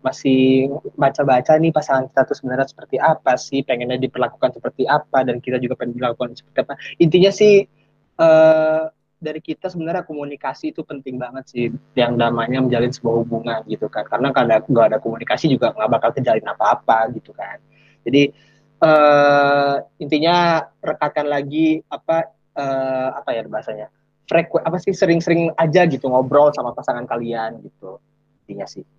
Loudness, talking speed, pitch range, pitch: -18 LUFS, 155 wpm, 125-160 Hz, 140 Hz